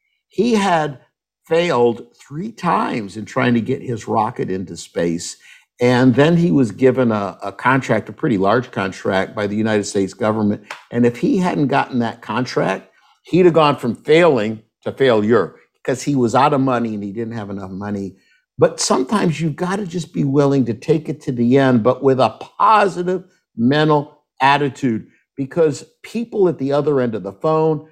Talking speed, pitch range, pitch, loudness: 185 wpm, 110-160 Hz, 130 Hz, -17 LUFS